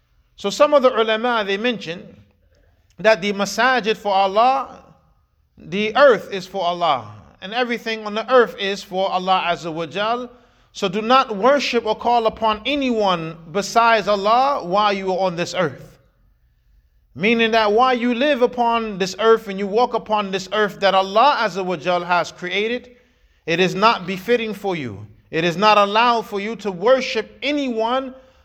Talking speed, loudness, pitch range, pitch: 170 wpm, -19 LUFS, 185-235 Hz, 210 Hz